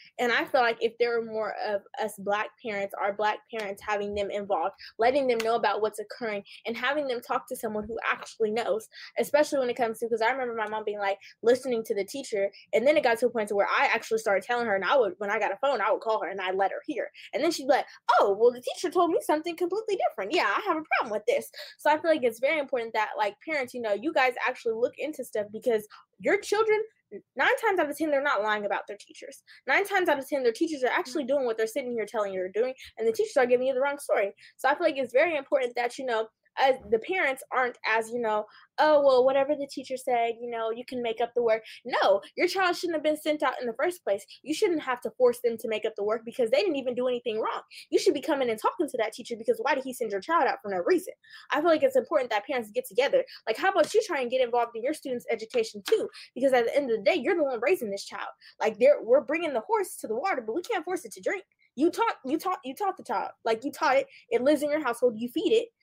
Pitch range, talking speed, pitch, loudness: 225-325 Hz, 285 wpm, 260 Hz, -27 LUFS